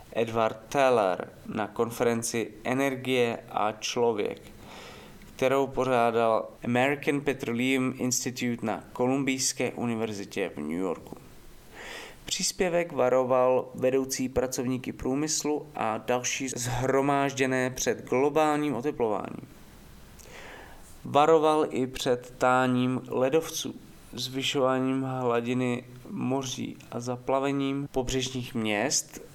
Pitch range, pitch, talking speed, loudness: 120-135 Hz, 130 Hz, 85 wpm, -28 LUFS